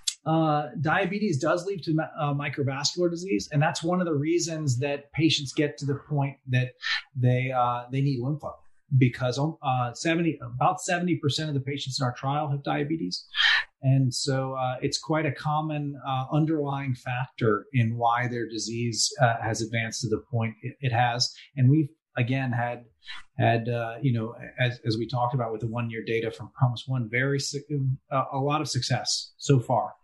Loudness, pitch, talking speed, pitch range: -27 LUFS, 135 Hz, 180 wpm, 120-150 Hz